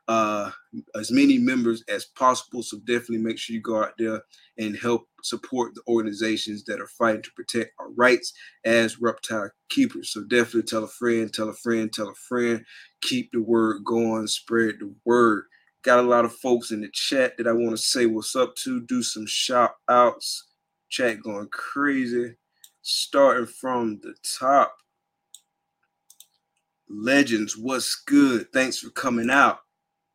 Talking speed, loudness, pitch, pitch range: 160 wpm, -23 LUFS, 120 Hz, 110-140 Hz